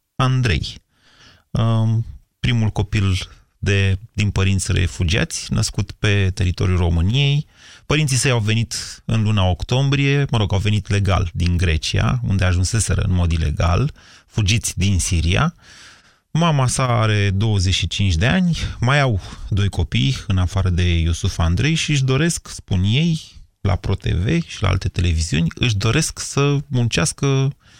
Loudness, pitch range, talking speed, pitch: -19 LUFS, 90-120 Hz, 135 wpm, 100 Hz